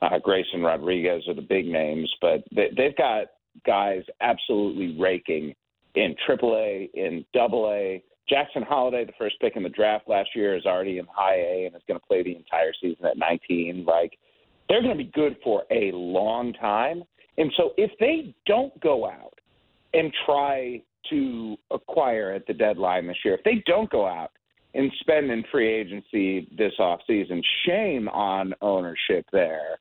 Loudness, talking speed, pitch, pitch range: -25 LUFS, 175 wpm, 105 Hz, 90-135 Hz